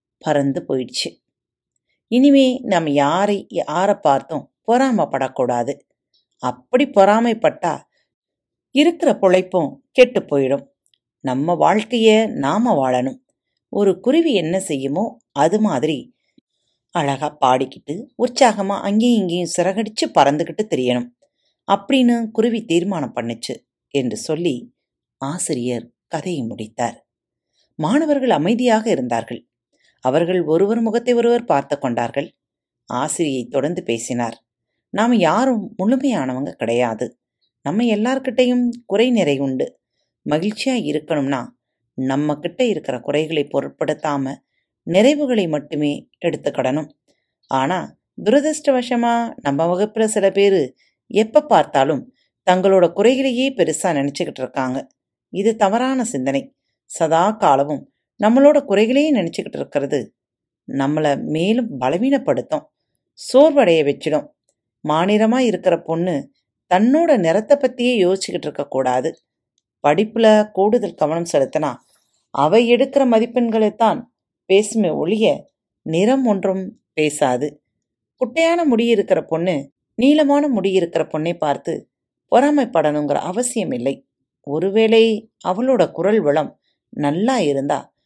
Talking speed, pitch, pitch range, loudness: 95 wpm, 195 Hz, 145-240 Hz, -18 LUFS